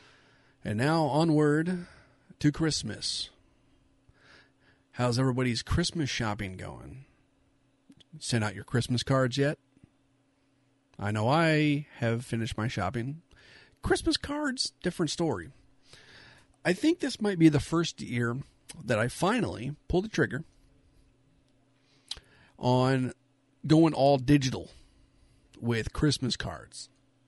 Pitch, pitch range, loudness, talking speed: 135 Hz, 120-155 Hz, -29 LUFS, 105 wpm